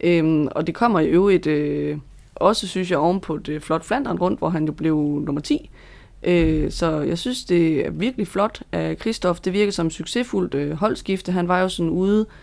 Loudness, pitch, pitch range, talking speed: -21 LUFS, 175 Hz, 155-195 Hz, 205 wpm